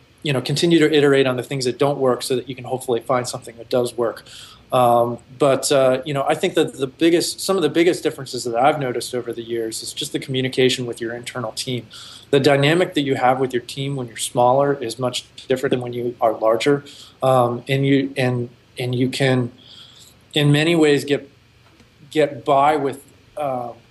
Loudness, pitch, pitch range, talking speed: -20 LUFS, 130 Hz, 120-140 Hz, 210 wpm